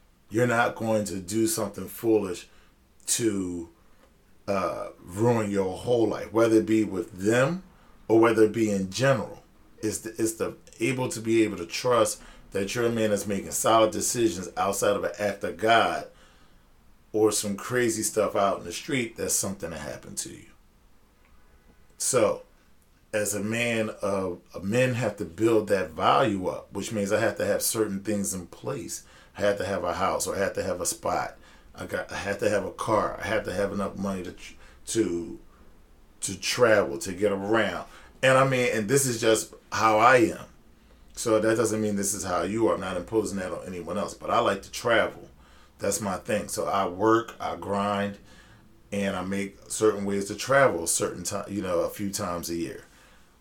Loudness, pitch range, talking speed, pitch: -26 LUFS, 95-110 Hz, 195 wpm, 105 Hz